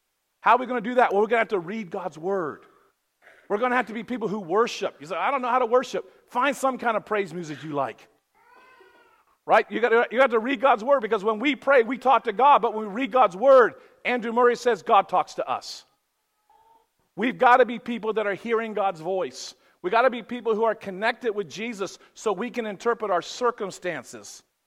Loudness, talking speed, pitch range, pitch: -24 LUFS, 230 wpm, 215-260 Hz, 235 Hz